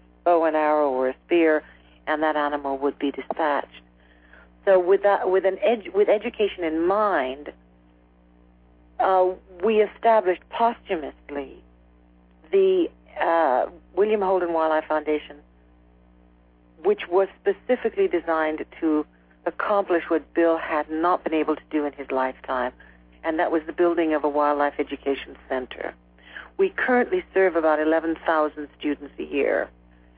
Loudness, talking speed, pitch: -23 LUFS, 135 wpm, 155 Hz